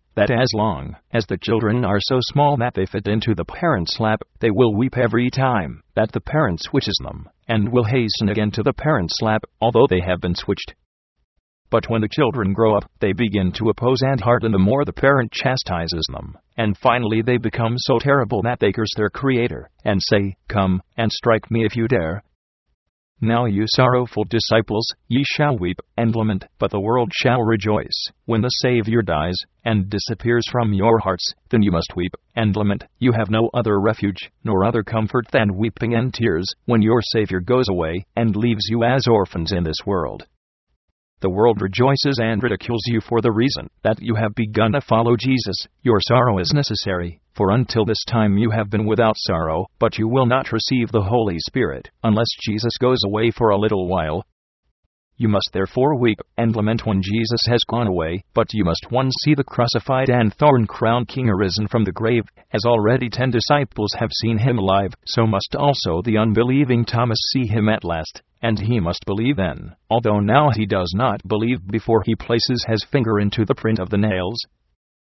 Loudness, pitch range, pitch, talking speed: -19 LUFS, 100-120 Hz, 110 Hz, 195 wpm